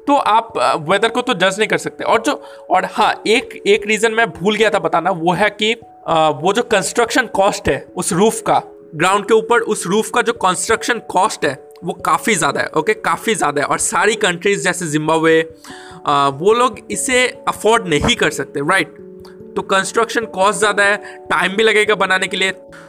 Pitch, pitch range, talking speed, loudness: 205 Hz, 185-230 Hz, 200 wpm, -15 LUFS